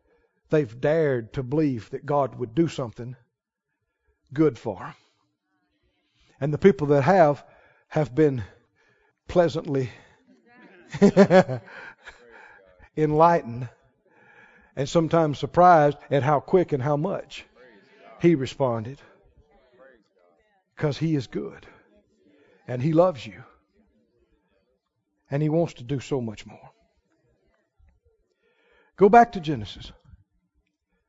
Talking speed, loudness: 100 wpm, -23 LUFS